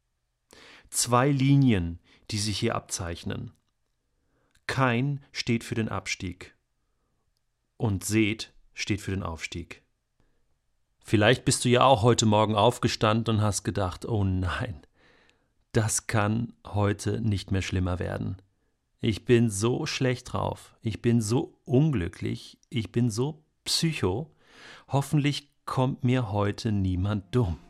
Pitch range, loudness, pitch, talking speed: 100-125 Hz, -27 LUFS, 110 Hz, 120 wpm